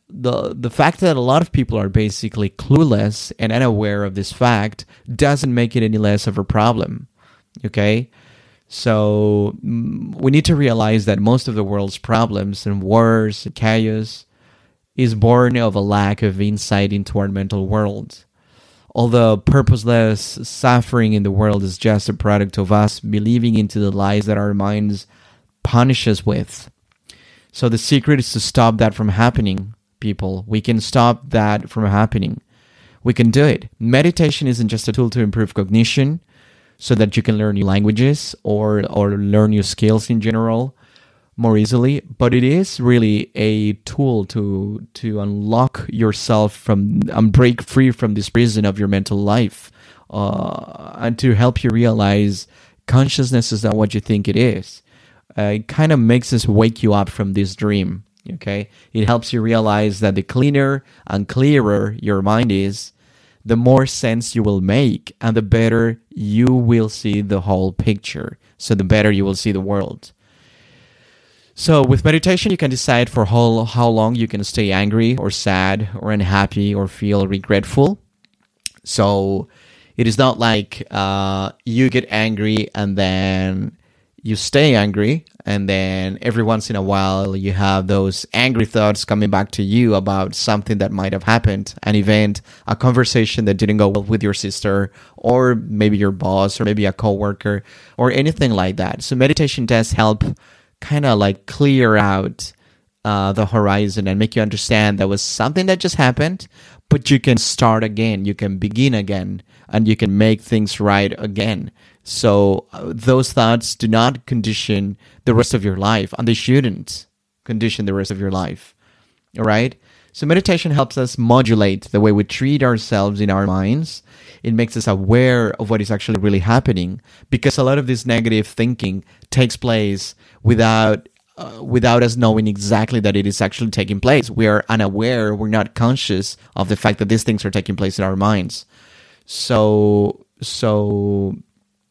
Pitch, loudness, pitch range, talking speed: 110 Hz, -16 LUFS, 100-120 Hz, 170 wpm